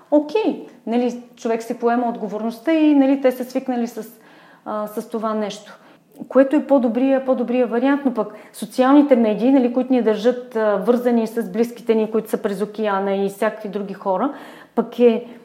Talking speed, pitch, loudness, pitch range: 175 wpm, 235 Hz, -19 LUFS, 220-255 Hz